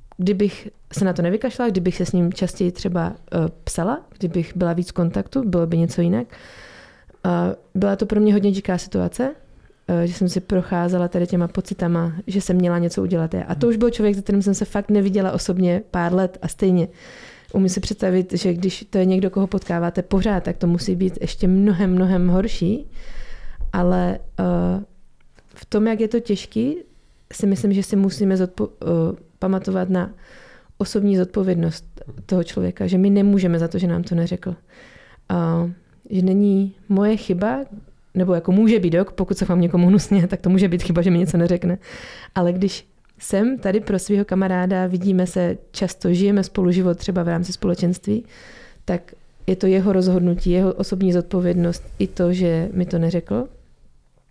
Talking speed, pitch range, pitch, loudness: 180 wpm, 175-200 Hz, 185 Hz, -20 LUFS